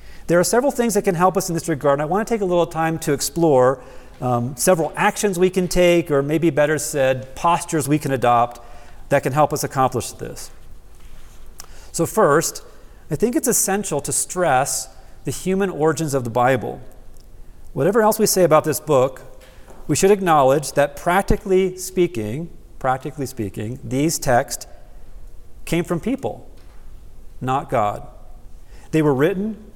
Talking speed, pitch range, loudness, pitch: 160 wpm, 130-180 Hz, -19 LUFS, 150 Hz